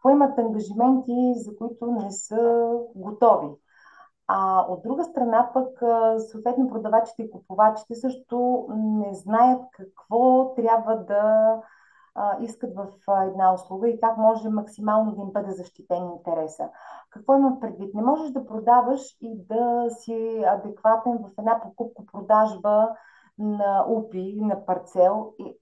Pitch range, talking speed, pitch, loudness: 205-240 Hz, 125 wpm, 225 Hz, -23 LUFS